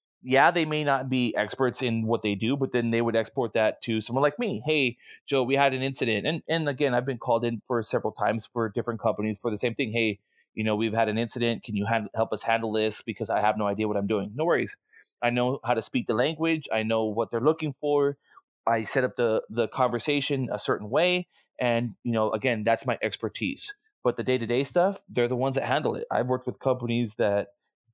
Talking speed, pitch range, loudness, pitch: 240 wpm, 115-135 Hz, -27 LUFS, 120 Hz